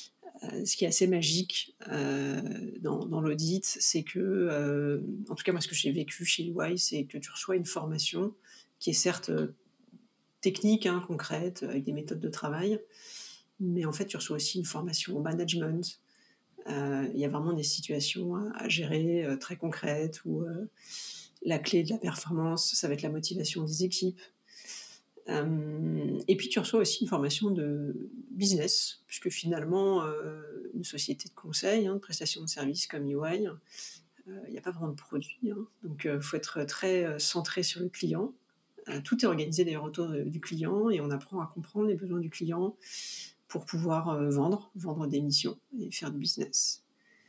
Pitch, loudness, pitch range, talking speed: 170 Hz, -32 LUFS, 150-195 Hz, 175 wpm